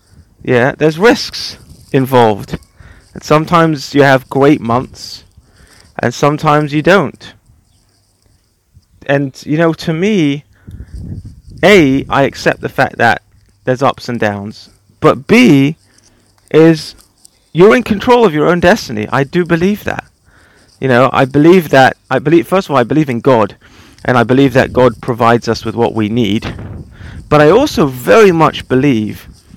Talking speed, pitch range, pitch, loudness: 150 wpm, 105-150 Hz, 125 Hz, -11 LUFS